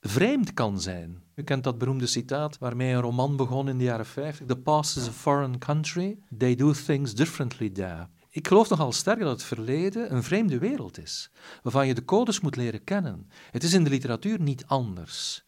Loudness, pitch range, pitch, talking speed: -27 LUFS, 120-155 Hz, 135 Hz, 205 wpm